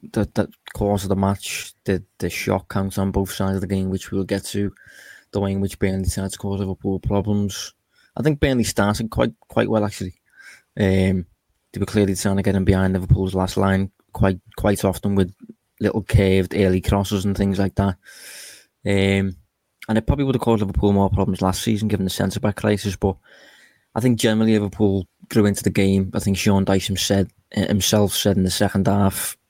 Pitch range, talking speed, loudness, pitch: 95-105 Hz, 200 wpm, -21 LUFS, 100 Hz